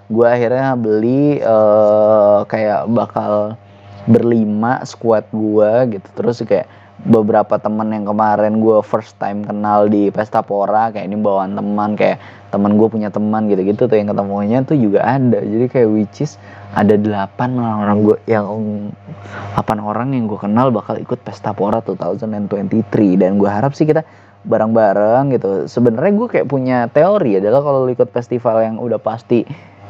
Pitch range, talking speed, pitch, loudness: 105-115 Hz, 160 wpm, 110 Hz, -15 LUFS